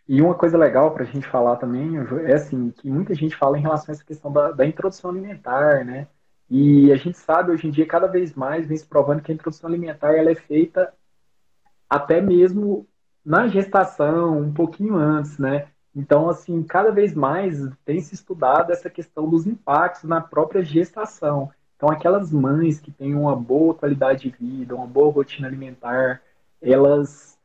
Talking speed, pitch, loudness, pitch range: 180 wpm, 155 Hz, -20 LUFS, 140-170 Hz